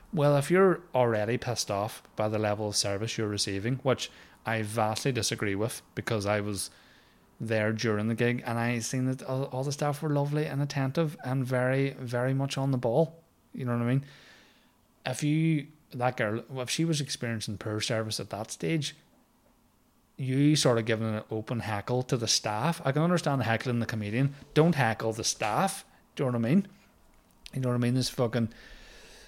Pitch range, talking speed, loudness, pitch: 110-140 Hz, 195 wpm, -29 LUFS, 125 Hz